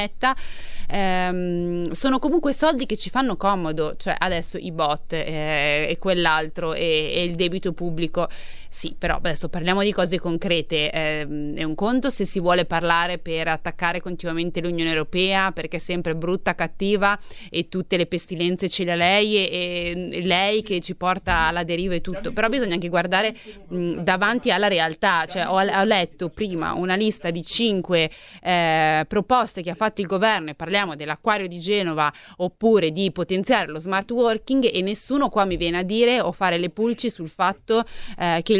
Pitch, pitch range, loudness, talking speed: 180 Hz, 170-205 Hz, -22 LUFS, 175 wpm